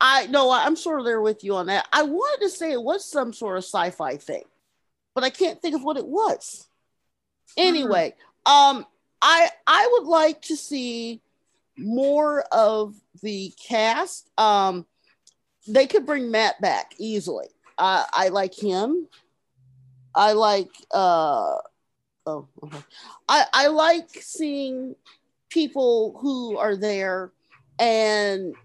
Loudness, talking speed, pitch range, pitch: -22 LUFS, 140 wpm, 210-320 Hz, 260 Hz